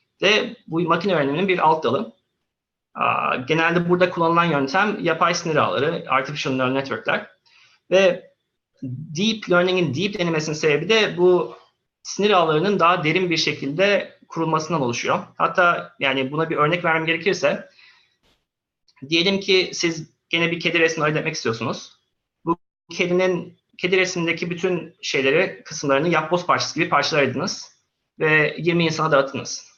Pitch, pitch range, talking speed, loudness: 170 Hz, 155-185 Hz, 135 wpm, -20 LUFS